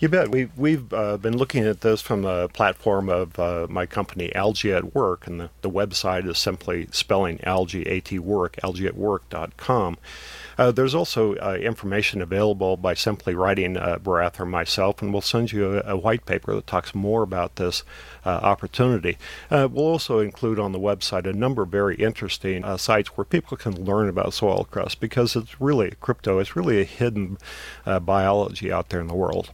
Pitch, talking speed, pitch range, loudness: 100 Hz, 190 wpm, 95-110 Hz, -23 LUFS